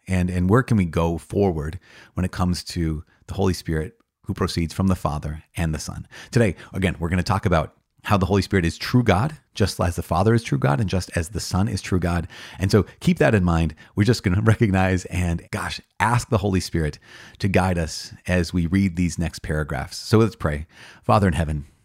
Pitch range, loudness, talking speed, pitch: 85-100 Hz, -22 LUFS, 230 wpm, 90 Hz